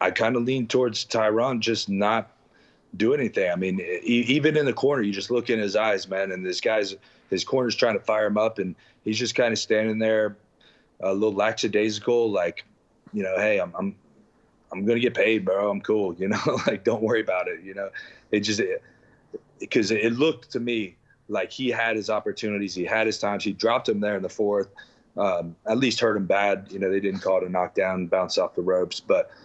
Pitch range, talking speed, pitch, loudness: 100-115 Hz, 220 wpm, 110 Hz, -24 LUFS